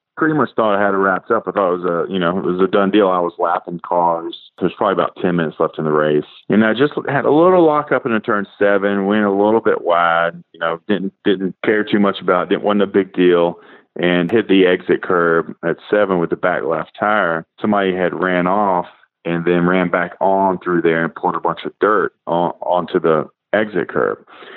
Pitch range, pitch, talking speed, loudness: 85-100 Hz, 90 Hz, 235 wpm, -16 LUFS